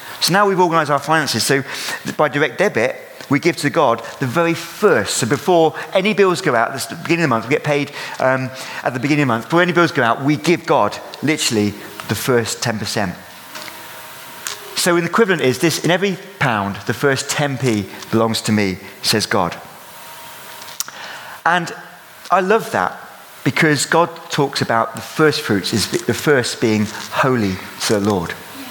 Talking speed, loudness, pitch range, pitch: 180 wpm, -17 LUFS, 115-165 Hz, 140 Hz